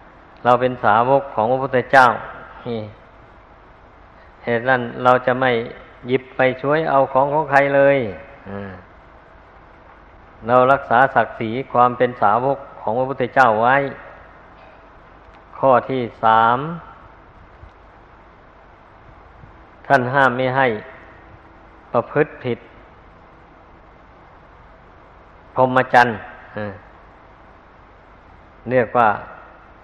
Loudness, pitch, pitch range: -17 LUFS, 120 Hz, 100-130 Hz